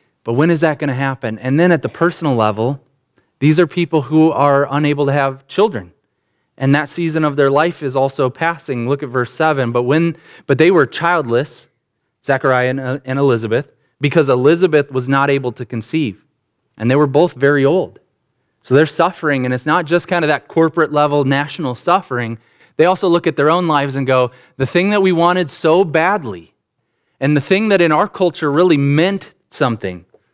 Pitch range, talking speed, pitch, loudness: 130-165 Hz, 190 wpm, 145 Hz, -15 LUFS